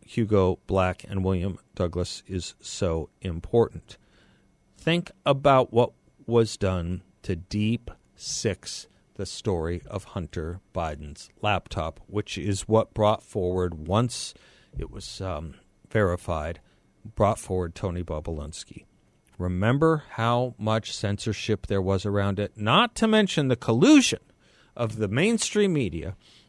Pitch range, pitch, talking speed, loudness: 90-115 Hz, 100 Hz, 120 wpm, -26 LUFS